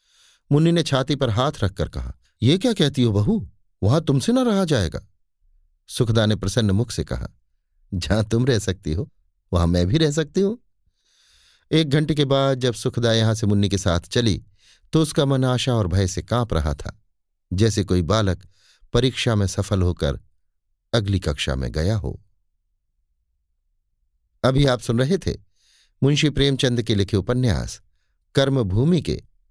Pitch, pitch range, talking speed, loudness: 105 Hz, 90-130 Hz, 165 wpm, -21 LUFS